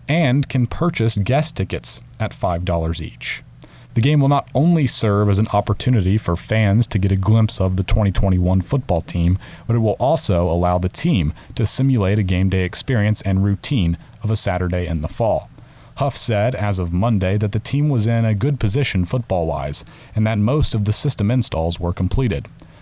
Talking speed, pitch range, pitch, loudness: 190 wpm, 95-125 Hz, 105 Hz, -19 LUFS